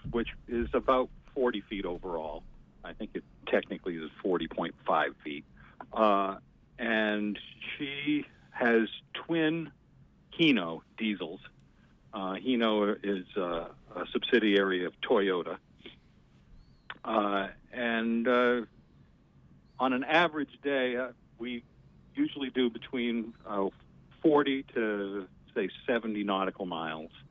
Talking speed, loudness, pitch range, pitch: 105 wpm, -31 LUFS, 100-125 Hz, 115 Hz